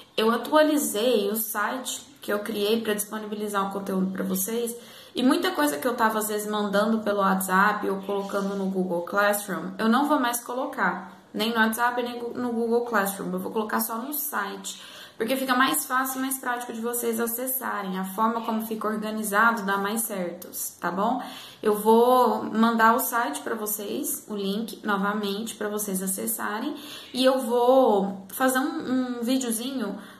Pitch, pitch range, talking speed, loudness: 220 Hz, 205-245 Hz, 175 wpm, -25 LUFS